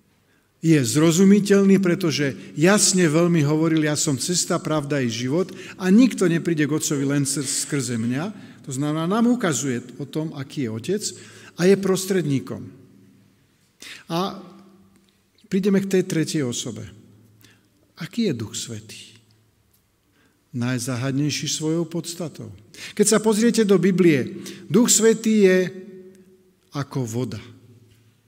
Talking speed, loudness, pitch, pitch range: 115 wpm, -21 LUFS, 155 Hz, 125-185 Hz